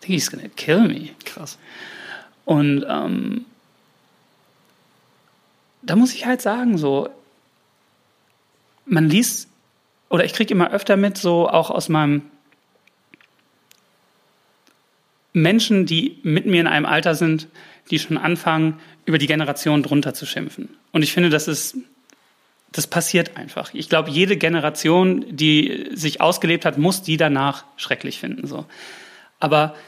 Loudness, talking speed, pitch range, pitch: -19 LUFS, 130 wpm, 155-195 Hz, 165 Hz